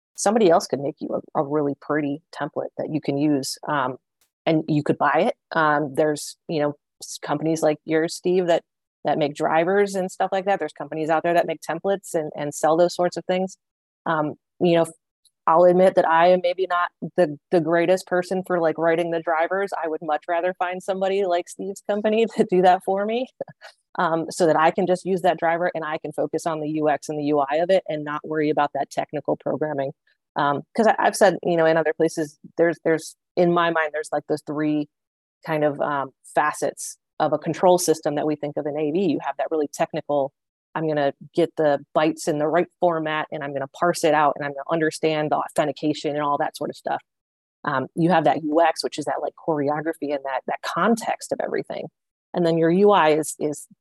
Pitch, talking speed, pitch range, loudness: 160 Hz, 225 wpm, 150-175 Hz, -22 LUFS